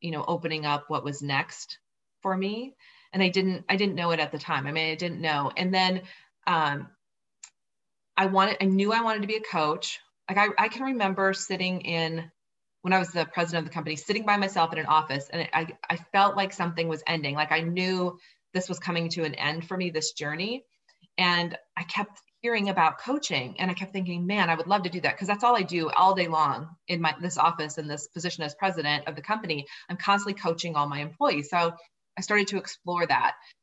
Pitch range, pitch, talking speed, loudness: 160-195 Hz, 175 Hz, 230 wpm, -27 LUFS